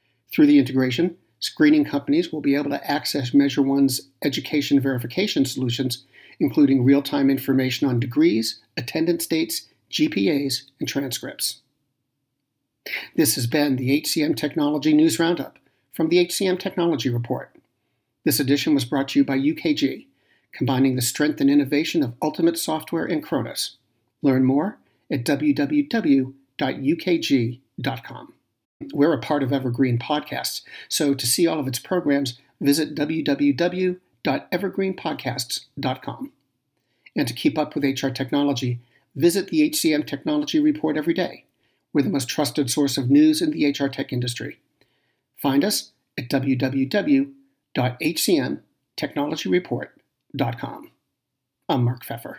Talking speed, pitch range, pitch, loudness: 125 wpm, 135-170 Hz, 145 Hz, -22 LUFS